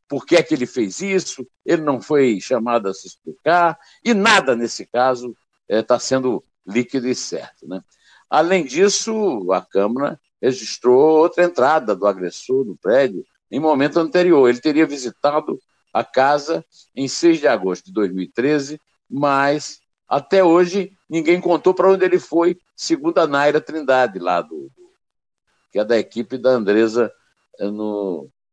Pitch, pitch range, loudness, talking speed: 145 Hz, 120-175 Hz, -18 LUFS, 150 wpm